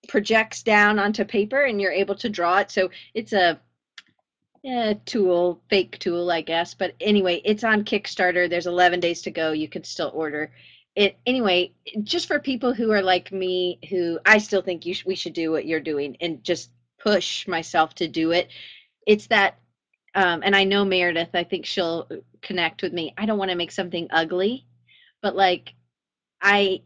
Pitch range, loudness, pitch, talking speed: 170-205 Hz, -22 LUFS, 185 Hz, 190 wpm